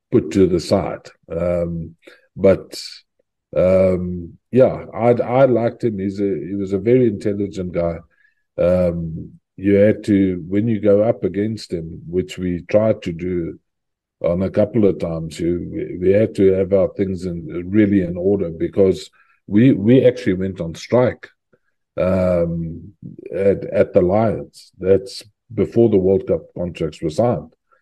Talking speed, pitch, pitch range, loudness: 150 wpm, 95 Hz, 90-105 Hz, -18 LUFS